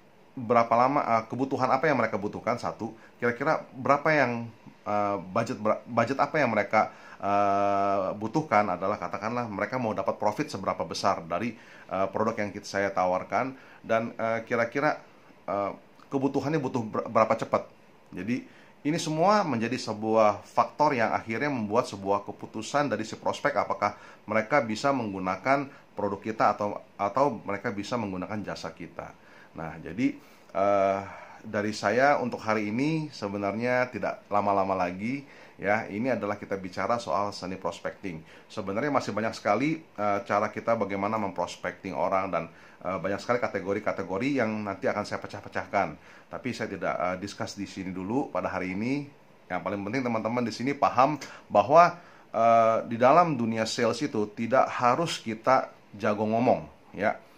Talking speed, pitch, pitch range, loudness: 145 wpm, 110 Hz, 100-125 Hz, -28 LUFS